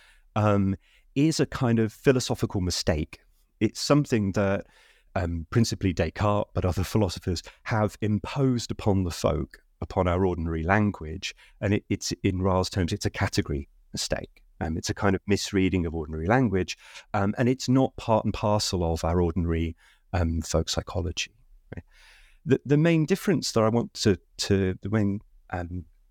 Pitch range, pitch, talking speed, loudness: 90-110 Hz, 100 Hz, 160 wpm, -26 LUFS